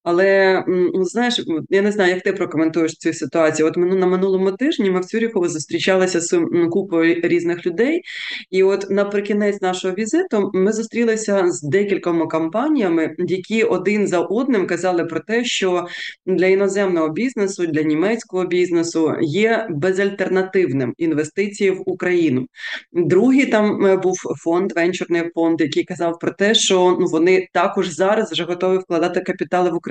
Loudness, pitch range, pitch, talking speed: -18 LUFS, 170-200 Hz, 185 Hz, 145 wpm